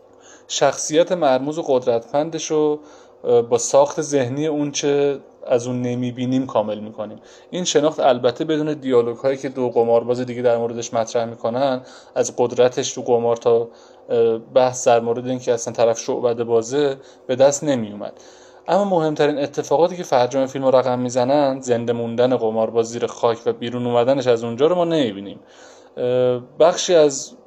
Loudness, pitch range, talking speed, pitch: -19 LUFS, 120-145 Hz, 150 wpm, 130 Hz